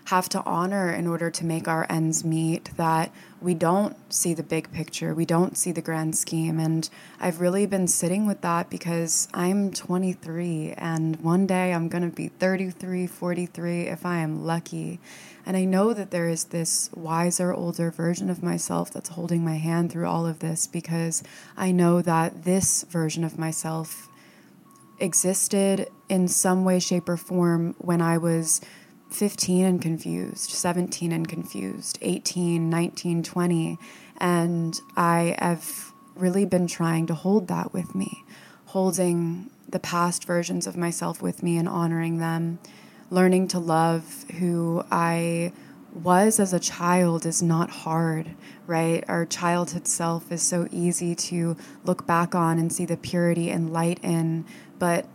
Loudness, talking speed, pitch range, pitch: -25 LUFS, 160 wpm, 165-180 Hz, 170 Hz